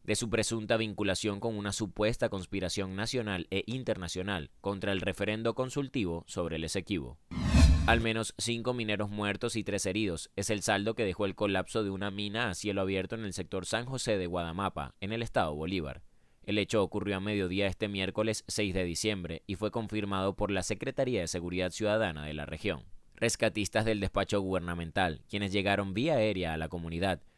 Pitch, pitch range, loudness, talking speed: 100 Hz, 95-110 Hz, -32 LUFS, 180 wpm